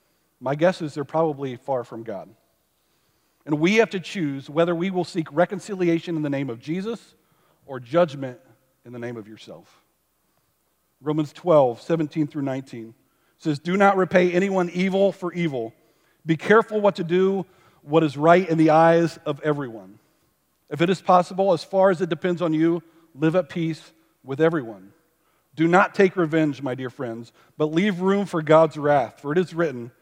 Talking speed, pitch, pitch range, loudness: 180 wpm, 160 Hz, 145-180 Hz, -22 LUFS